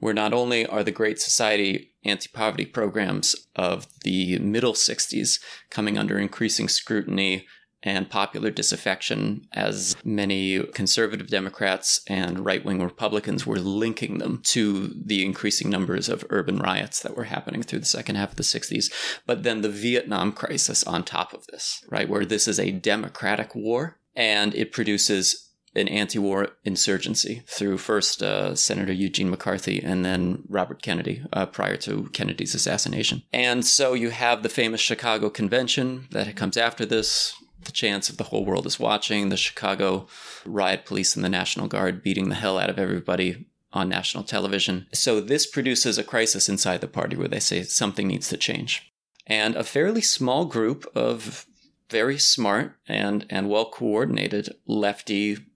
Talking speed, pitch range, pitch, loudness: 165 wpm, 95-115 Hz, 105 Hz, -24 LUFS